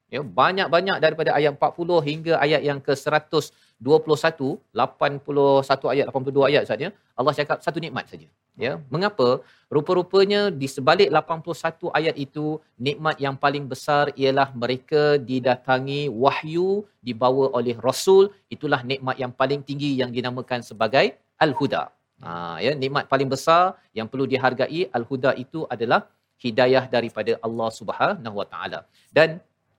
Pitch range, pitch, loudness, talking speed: 130-155 Hz, 140 Hz, -22 LUFS, 130 wpm